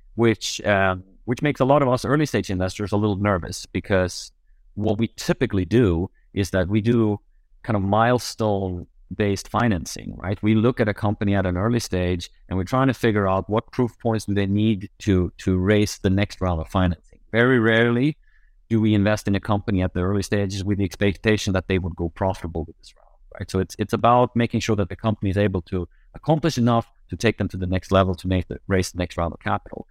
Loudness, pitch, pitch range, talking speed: -22 LUFS, 100 Hz, 95-115 Hz, 225 wpm